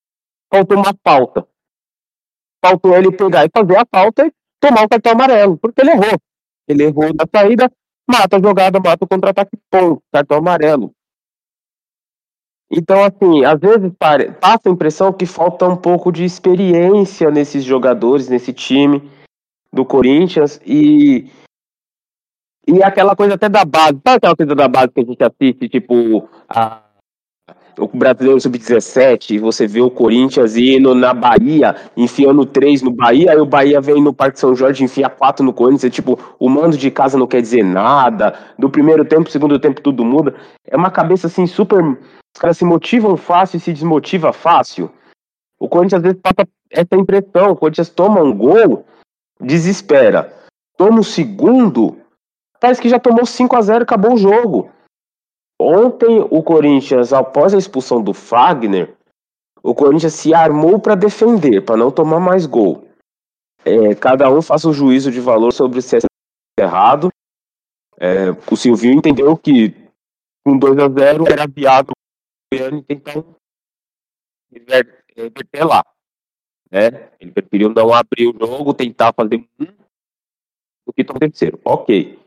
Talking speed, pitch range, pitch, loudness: 155 wpm, 135-195 Hz, 155 Hz, -12 LUFS